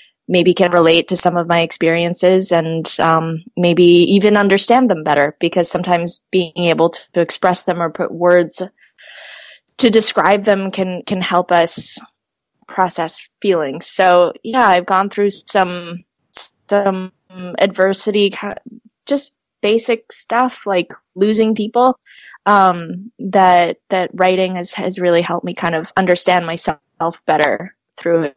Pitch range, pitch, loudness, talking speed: 170-200 Hz, 185 Hz, -15 LUFS, 135 wpm